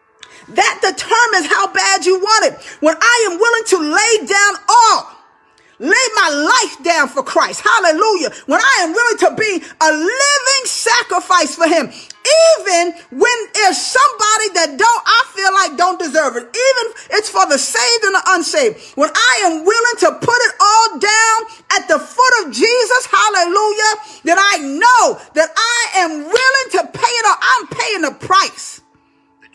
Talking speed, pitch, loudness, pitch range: 170 wpm, 390 Hz, -12 LUFS, 340-445 Hz